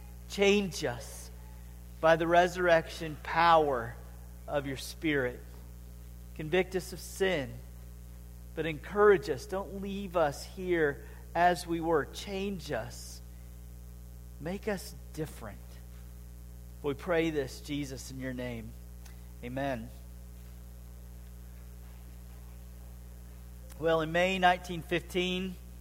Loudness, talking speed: -31 LUFS, 95 wpm